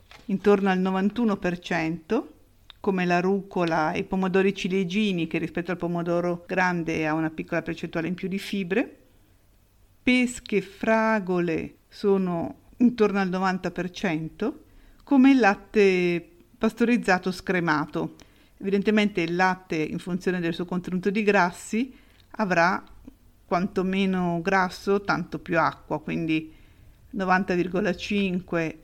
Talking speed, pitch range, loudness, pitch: 110 wpm, 170-200 Hz, -25 LUFS, 185 Hz